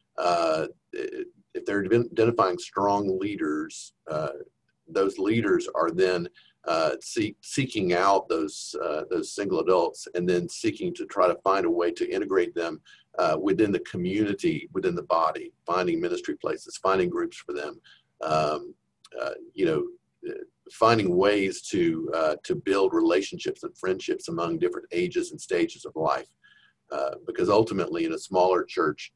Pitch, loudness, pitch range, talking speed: 355 Hz, -26 LUFS, 315-375 Hz, 150 wpm